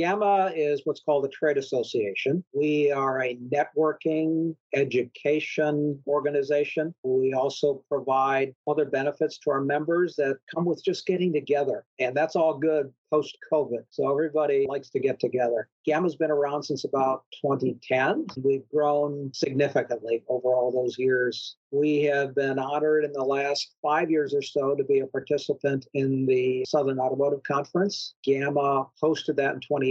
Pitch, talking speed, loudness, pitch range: 145 Hz, 155 wpm, -26 LUFS, 135-155 Hz